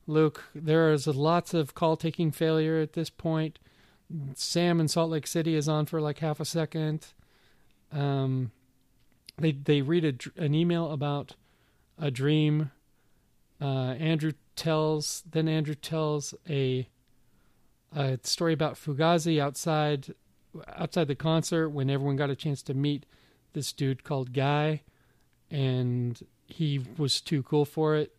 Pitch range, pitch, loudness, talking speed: 140-160 Hz, 150 Hz, -29 LUFS, 140 wpm